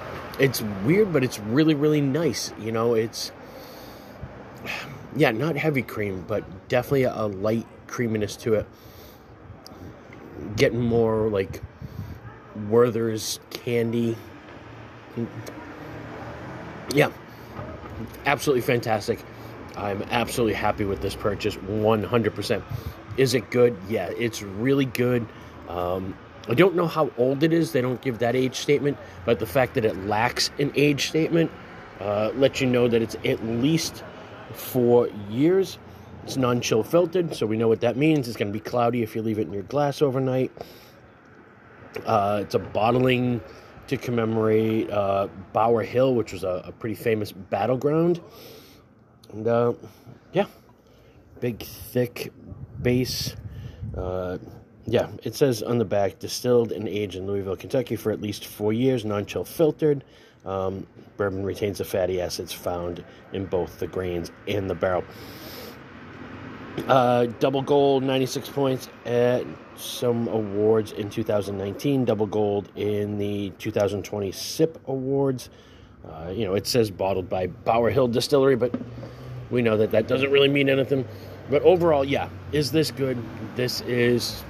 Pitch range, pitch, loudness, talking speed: 105-130 Hz, 115 Hz, -24 LUFS, 140 wpm